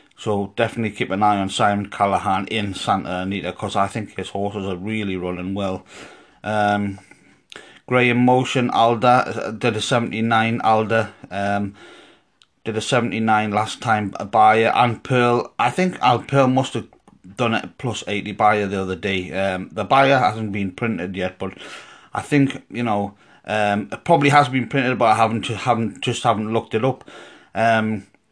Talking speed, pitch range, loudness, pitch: 170 wpm, 100-120 Hz, -20 LUFS, 110 Hz